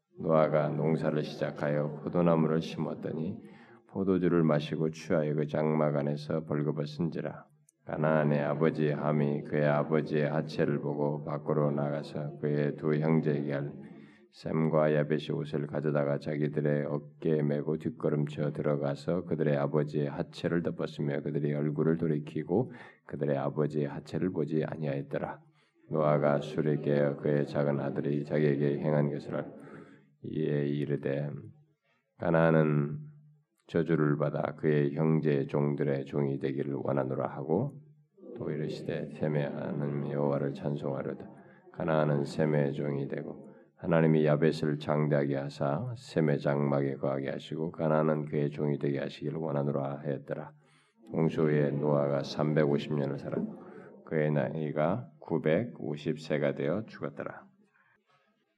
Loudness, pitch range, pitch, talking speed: -31 LUFS, 70-80 Hz, 75 Hz, 305 characters per minute